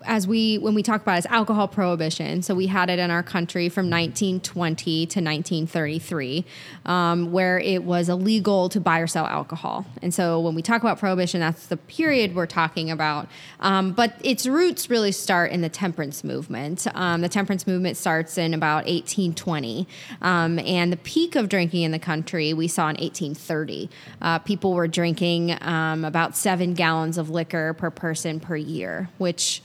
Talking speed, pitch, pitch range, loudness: 180 wpm, 175 Hz, 165-190 Hz, -23 LUFS